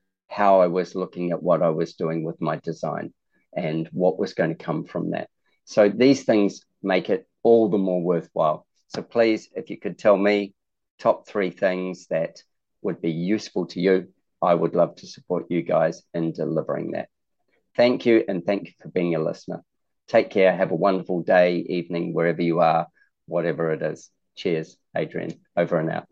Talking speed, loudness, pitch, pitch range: 190 wpm, -23 LUFS, 90 Hz, 85-100 Hz